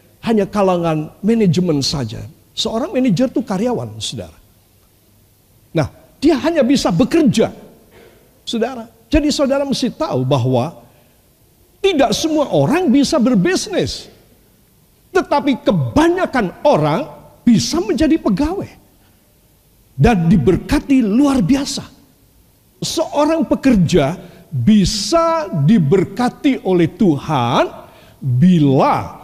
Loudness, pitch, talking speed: -16 LUFS, 215 Hz, 85 wpm